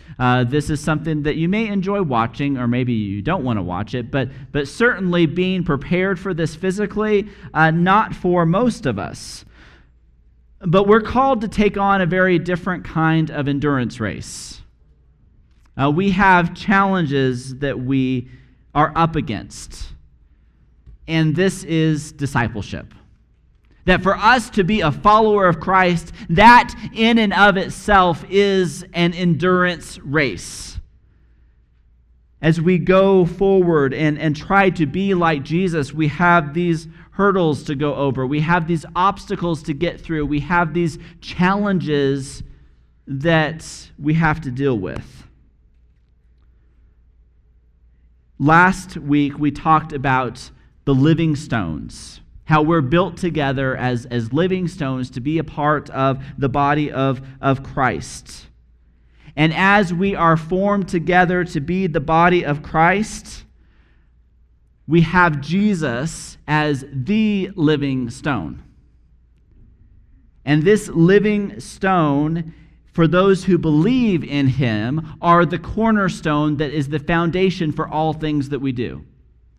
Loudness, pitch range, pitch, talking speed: -18 LUFS, 125-180 Hz, 155 Hz, 135 wpm